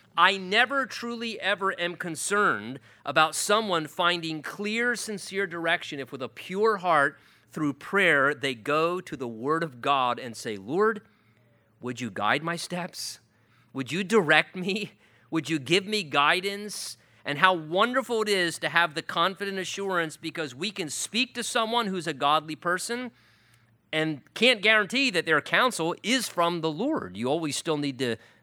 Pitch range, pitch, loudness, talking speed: 145-205 Hz, 170 Hz, -26 LUFS, 165 wpm